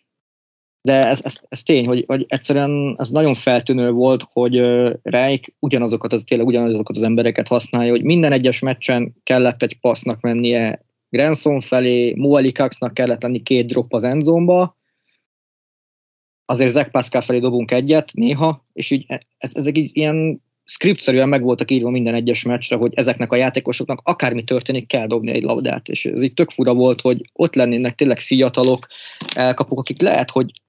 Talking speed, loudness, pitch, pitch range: 165 wpm, -17 LUFS, 125 Hz, 120-140 Hz